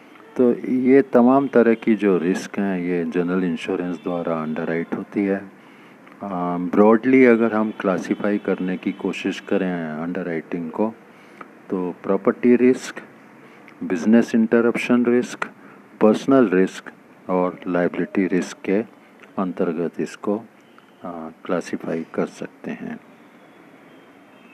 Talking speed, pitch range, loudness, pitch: 110 wpm, 90-115 Hz, -20 LUFS, 100 Hz